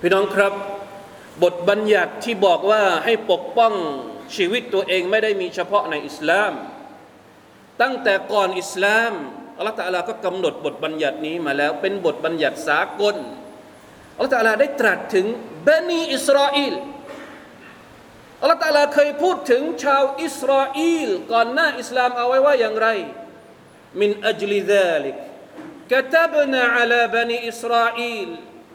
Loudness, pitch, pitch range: -19 LUFS, 230 Hz, 200-280 Hz